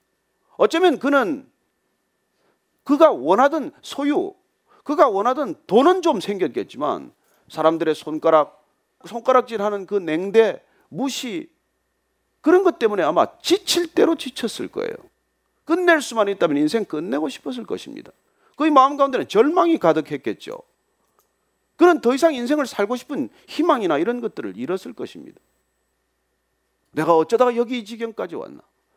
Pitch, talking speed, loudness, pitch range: 260 Hz, 290 characters per minute, -20 LUFS, 200-325 Hz